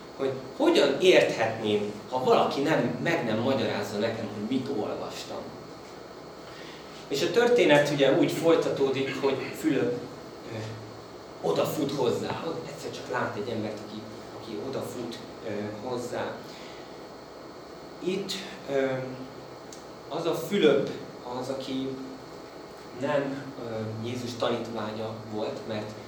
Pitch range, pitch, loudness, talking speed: 110-135 Hz, 125 Hz, -28 LUFS, 105 wpm